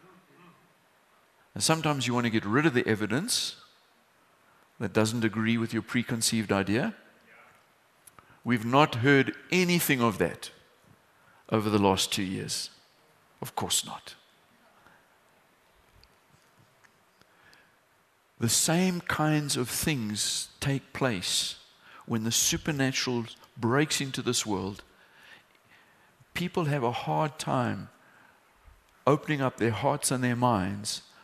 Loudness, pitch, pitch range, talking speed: -28 LUFS, 125 Hz, 110-145 Hz, 110 wpm